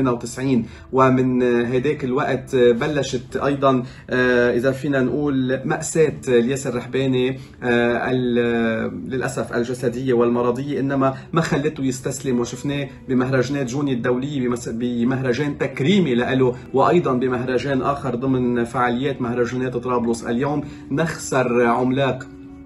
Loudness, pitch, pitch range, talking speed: -20 LUFS, 130 Hz, 120-135 Hz, 95 wpm